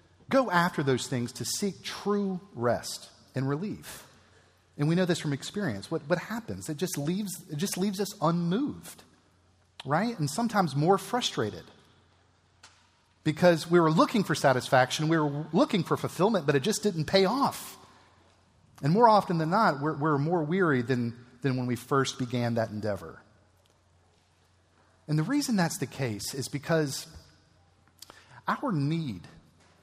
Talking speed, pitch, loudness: 155 wpm, 140 Hz, -28 LUFS